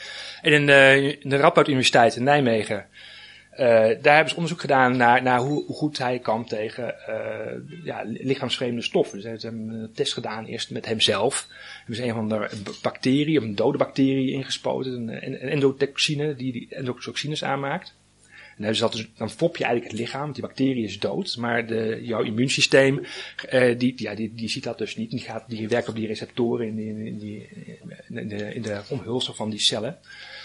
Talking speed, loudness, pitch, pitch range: 195 wpm, -23 LUFS, 125 Hz, 110-135 Hz